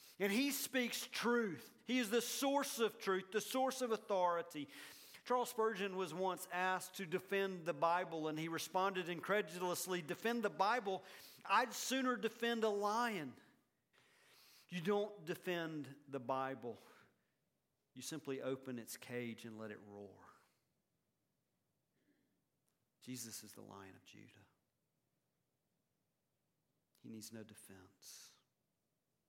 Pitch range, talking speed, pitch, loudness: 135-220 Hz, 120 wpm, 185 Hz, -40 LUFS